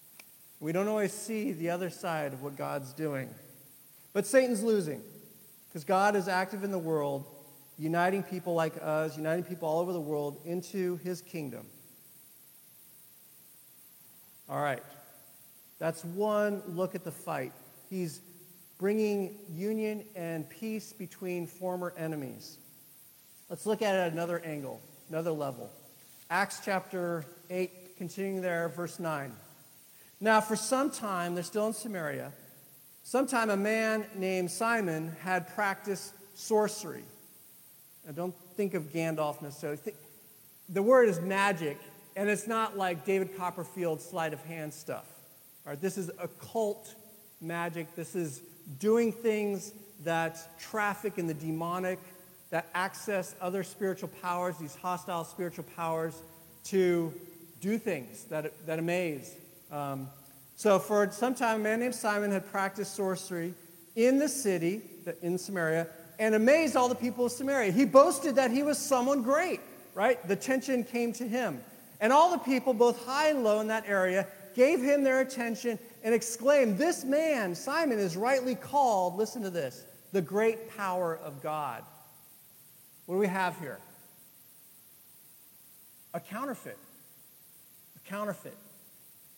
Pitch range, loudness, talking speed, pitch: 165-215 Hz, -31 LUFS, 140 wpm, 185 Hz